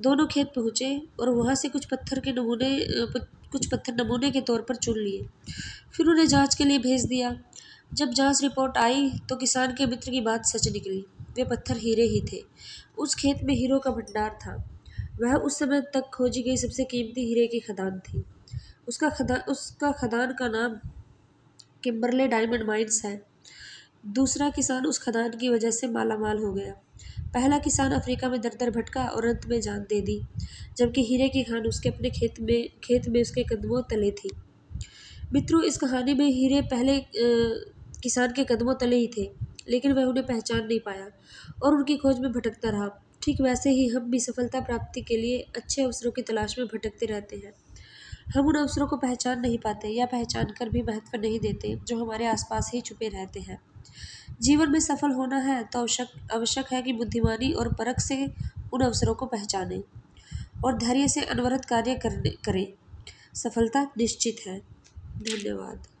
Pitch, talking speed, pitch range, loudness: 245 Hz, 180 wpm, 225-265 Hz, -27 LUFS